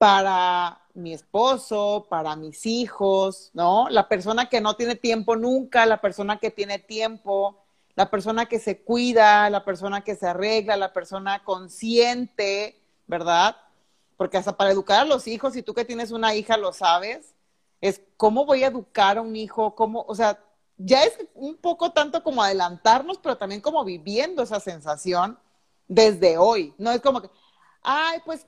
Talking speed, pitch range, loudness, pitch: 170 wpm, 195-235 Hz, -22 LUFS, 215 Hz